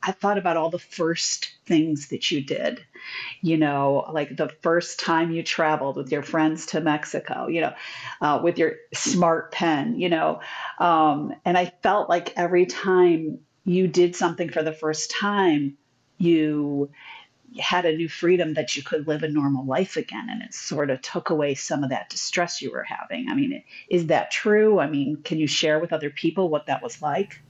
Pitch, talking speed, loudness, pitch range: 165 Hz, 195 wpm, -24 LUFS, 150-180 Hz